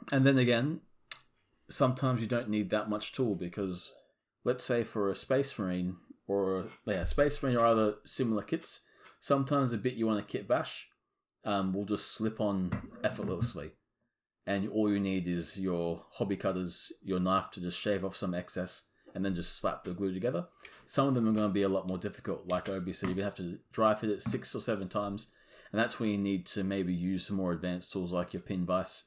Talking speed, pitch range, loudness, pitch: 215 wpm, 95-115 Hz, -32 LUFS, 100 Hz